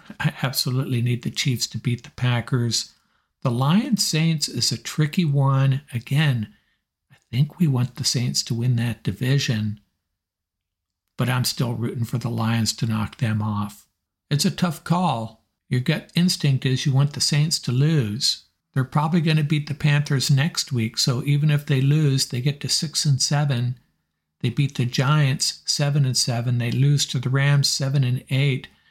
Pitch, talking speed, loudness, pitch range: 135 Hz, 180 wpm, -22 LUFS, 120-145 Hz